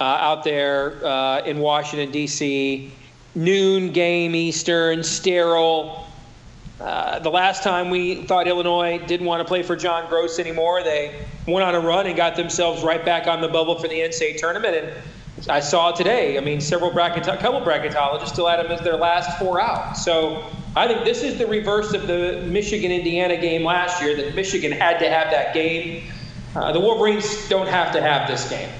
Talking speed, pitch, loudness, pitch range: 190 wpm, 170 Hz, -20 LUFS, 155-180 Hz